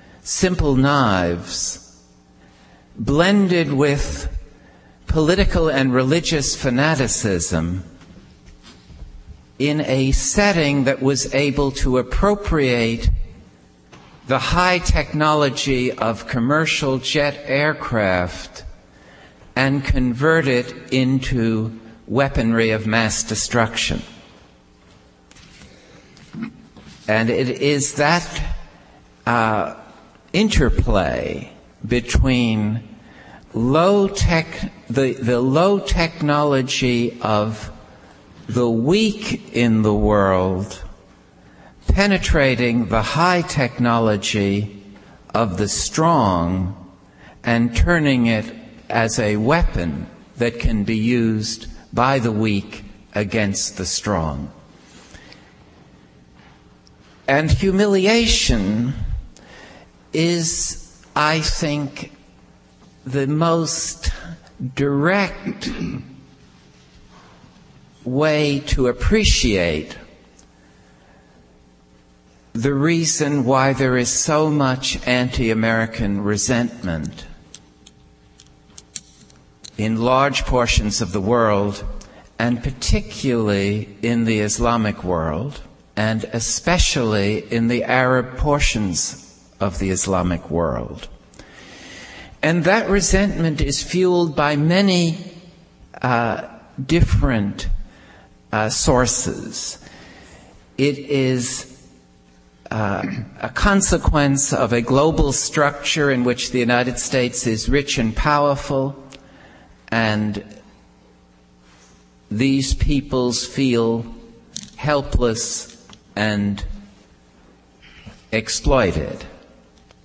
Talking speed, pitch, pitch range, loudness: 75 wpm, 115 Hz, 95-140 Hz, -19 LUFS